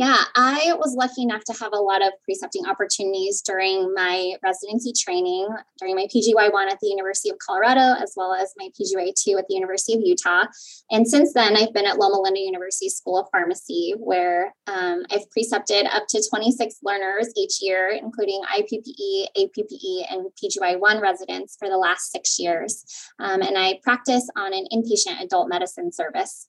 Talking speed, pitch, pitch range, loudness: 175 wpm, 215 Hz, 195-265 Hz, -22 LUFS